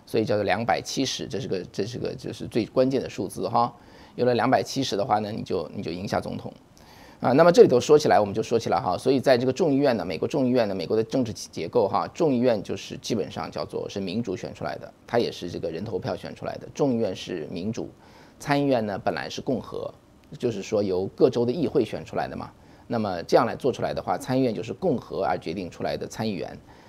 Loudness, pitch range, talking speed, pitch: -25 LUFS, 105-130 Hz, 365 characters per minute, 120 Hz